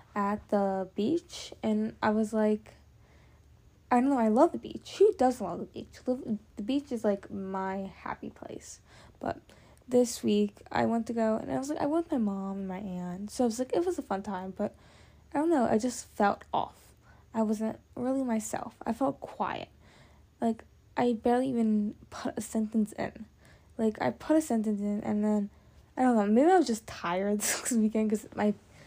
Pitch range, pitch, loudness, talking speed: 205-250 Hz, 220 Hz, -30 LUFS, 200 wpm